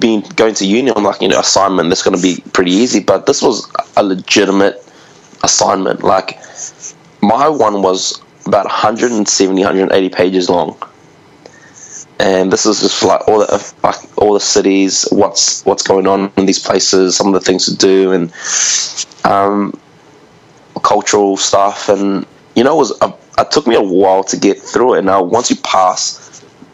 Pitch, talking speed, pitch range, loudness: 95 Hz, 170 wpm, 95-100 Hz, -11 LUFS